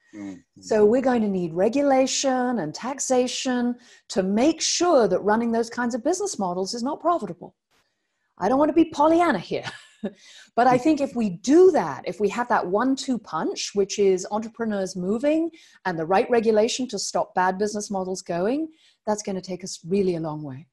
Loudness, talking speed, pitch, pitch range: -23 LUFS, 190 wpm, 225 Hz, 190-265 Hz